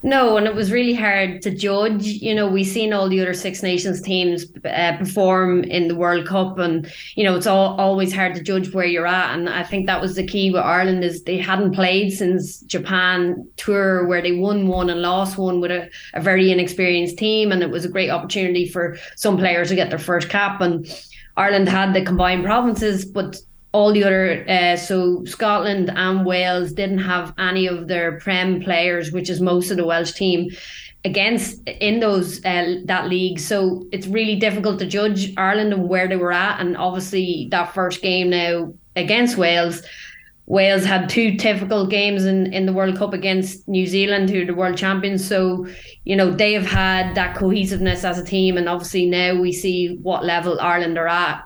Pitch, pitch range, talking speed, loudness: 185 Hz, 180-195 Hz, 200 wpm, -19 LUFS